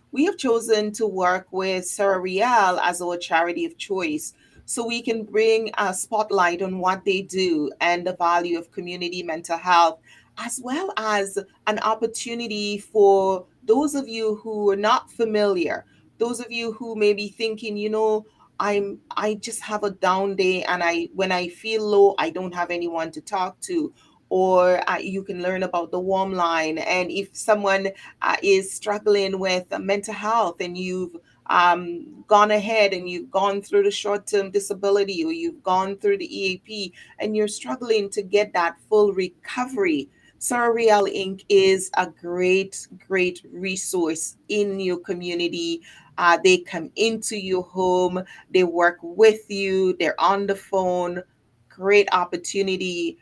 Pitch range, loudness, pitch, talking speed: 180-215 Hz, -22 LUFS, 195 Hz, 160 wpm